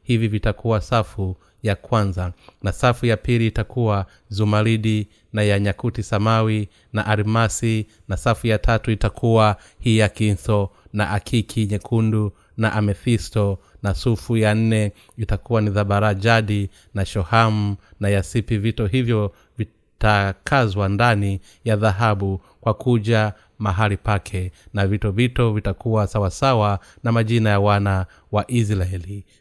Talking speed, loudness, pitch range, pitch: 120 wpm, -21 LUFS, 100-115 Hz, 105 Hz